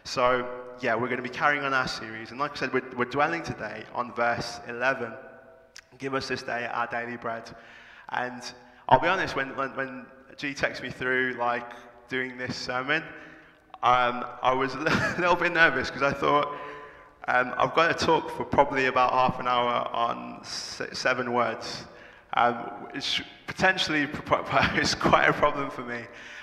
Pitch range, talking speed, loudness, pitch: 120-140 Hz, 170 wpm, -26 LUFS, 125 Hz